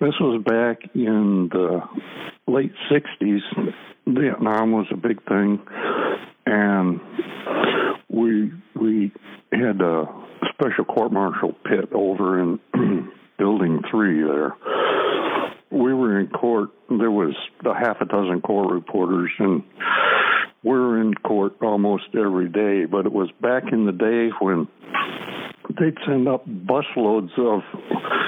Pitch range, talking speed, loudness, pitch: 100-120 Hz, 125 wpm, -21 LUFS, 110 Hz